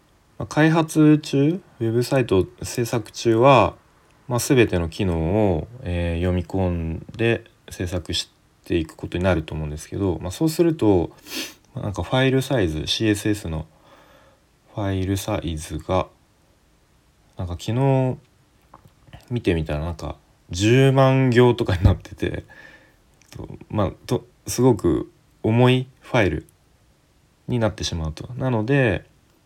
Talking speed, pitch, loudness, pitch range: 235 characters per minute, 110 Hz, -21 LUFS, 90-130 Hz